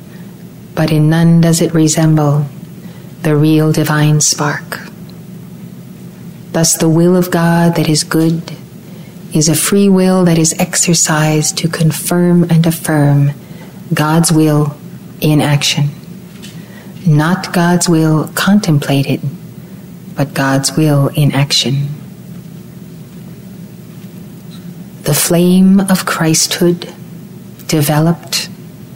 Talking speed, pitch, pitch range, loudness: 95 wpm, 170 Hz, 155-180 Hz, -11 LUFS